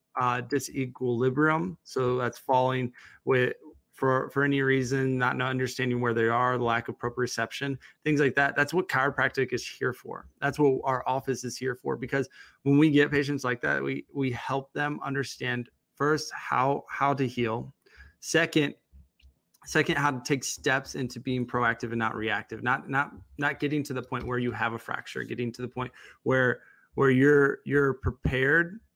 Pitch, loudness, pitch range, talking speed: 130 Hz, -28 LUFS, 125-140 Hz, 175 wpm